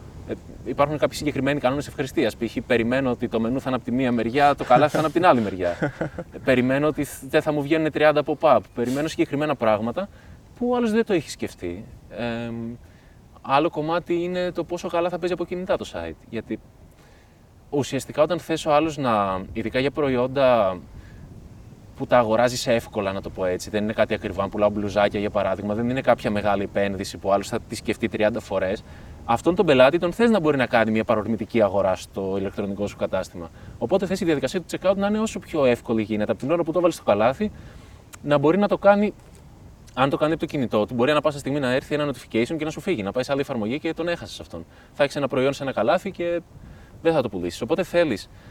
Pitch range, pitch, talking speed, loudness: 105-155 Hz, 125 Hz, 215 wpm, -23 LUFS